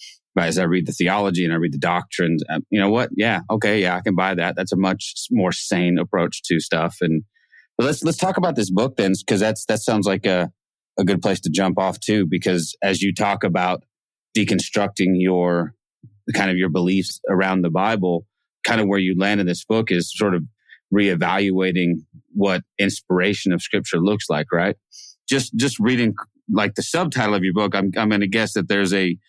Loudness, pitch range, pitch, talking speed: -20 LUFS, 90-105 Hz, 95 Hz, 205 wpm